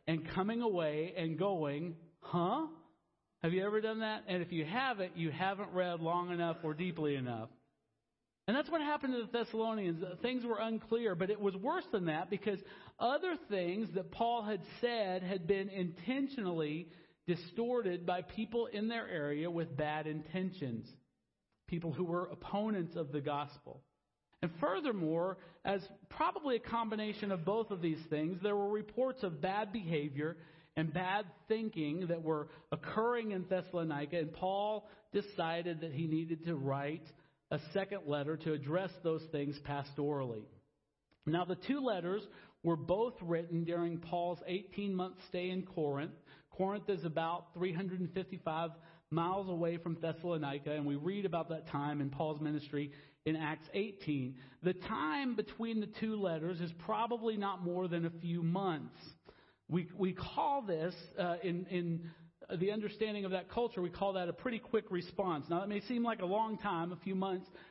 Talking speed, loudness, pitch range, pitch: 165 wpm, -38 LUFS, 160-205 Hz, 180 Hz